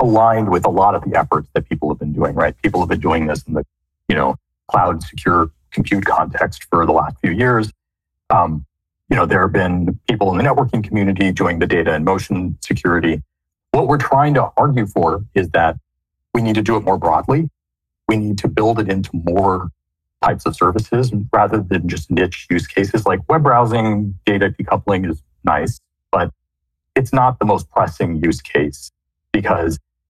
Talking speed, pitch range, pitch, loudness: 190 wpm, 80-110 Hz, 95 Hz, -17 LUFS